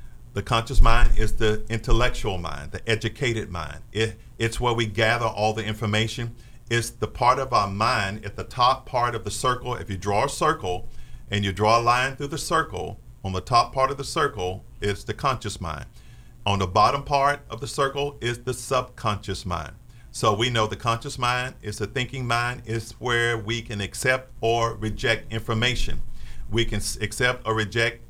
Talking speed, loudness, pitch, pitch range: 190 wpm, -25 LUFS, 115 Hz, 105-125 Hz